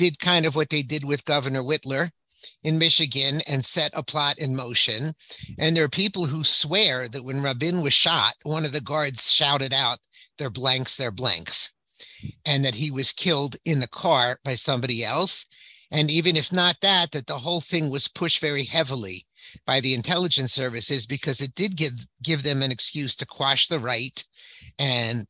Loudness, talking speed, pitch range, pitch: -22 LUFS, 185 wpm, 130-155 Hz, 145 Hz